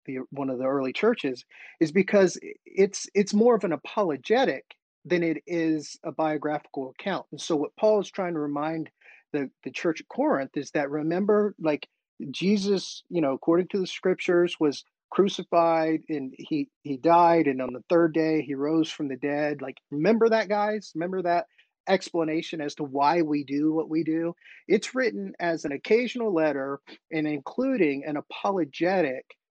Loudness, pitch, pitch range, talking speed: -26 LUFS, 160 Hz, 145-190 Hz, 175 wpm